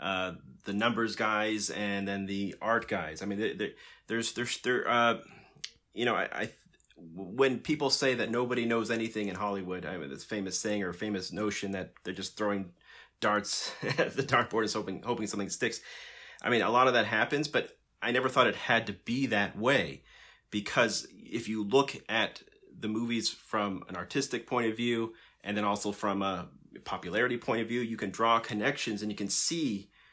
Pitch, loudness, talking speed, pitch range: 105 Hz, -31 LUFS, 195 wpm, 100-115 Hz